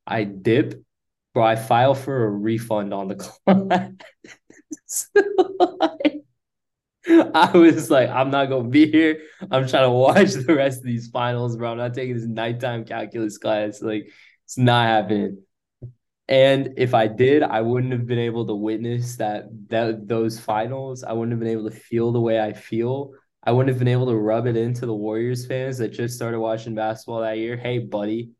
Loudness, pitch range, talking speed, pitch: -21 LUFS, 110-130 Hz, 190 wpm, 120 Hz